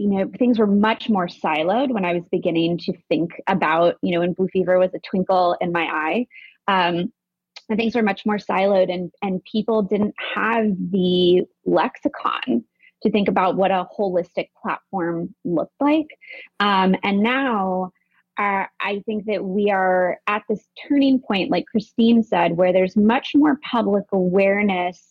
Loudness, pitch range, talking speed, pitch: -20 LUFS, 180-220 Hz, 165 wpm, 195 Hz